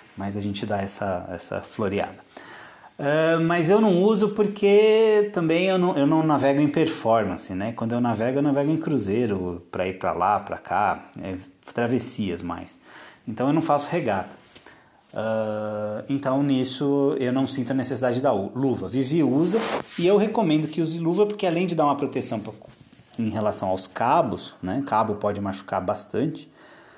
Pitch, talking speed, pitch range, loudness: 135 Hz, 170 wpm, 110-165 Hz, -23 LUFS